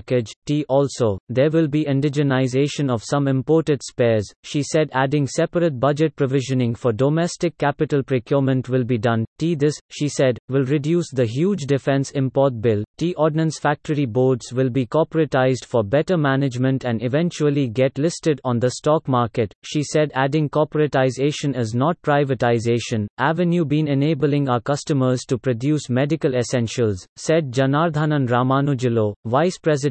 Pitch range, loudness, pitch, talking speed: 125-155 Hz, -20 LUFS, 140 Hz, 150 wpm